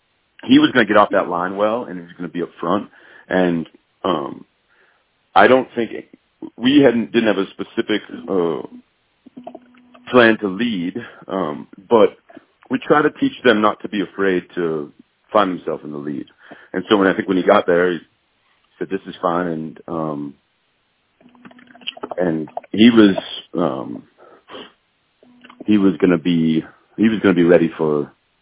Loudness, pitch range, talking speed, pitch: -18 LUFS, 85-125 Hz, 170 wpm, 100 Hz